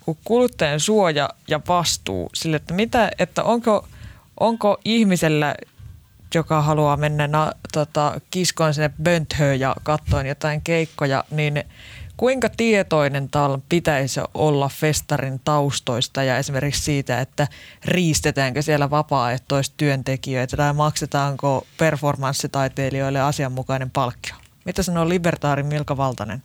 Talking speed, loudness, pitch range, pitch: 110 wpm, -21 LUFS, 135-160 Hz, 145 Hz